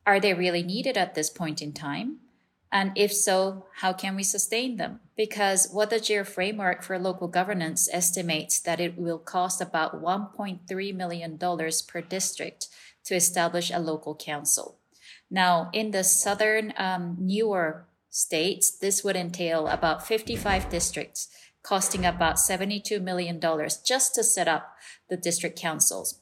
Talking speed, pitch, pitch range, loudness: 145 wpm, 185 Hz, 170-200 Hz, -26 LUFS